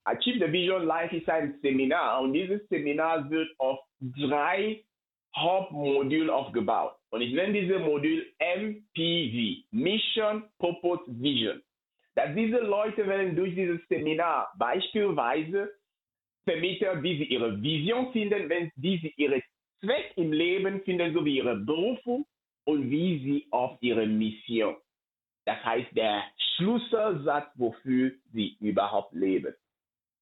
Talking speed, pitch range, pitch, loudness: 125 wpm, 140-200 Hz, 170 Hz, -29 LUFS